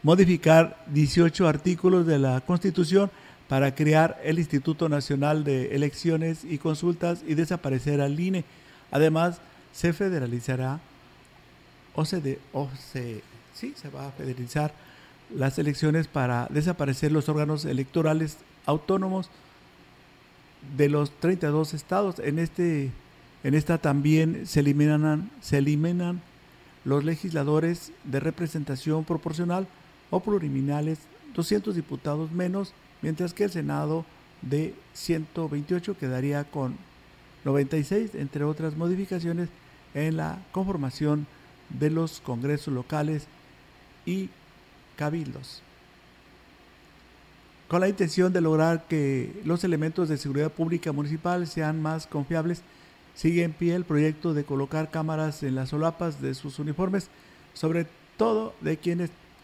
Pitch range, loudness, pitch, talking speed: 145-170 Hz, -27 LUFS, 155 Hz, 115 wpm